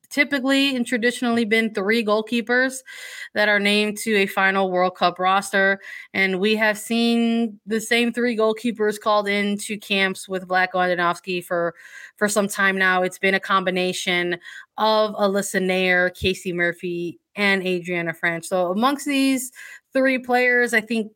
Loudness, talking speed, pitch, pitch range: -21 LUFS, 150 wpm, 205 Hz, 185-235 Hz